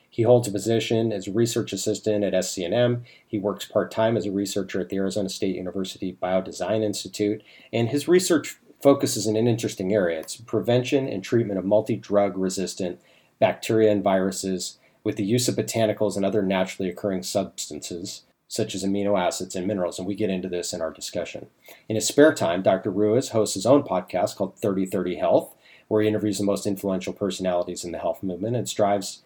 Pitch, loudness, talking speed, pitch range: 105 Hz, -24 LUFS, 190 wpm, 95-110 Hz